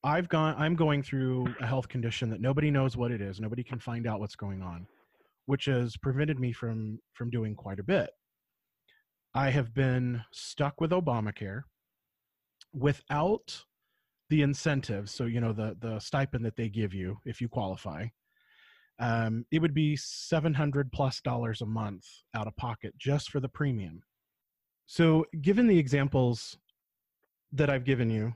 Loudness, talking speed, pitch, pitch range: -31 LUFS, 165 wpm, 125 Hz, 115-145 Hz